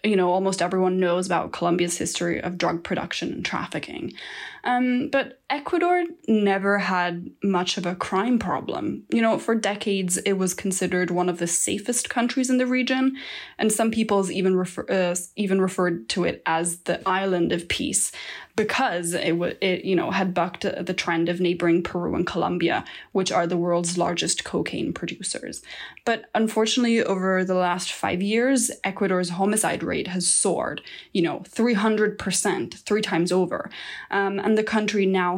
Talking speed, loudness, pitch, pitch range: 165 wpm, -24 LUFS, 190 Hz, 180-220 Hz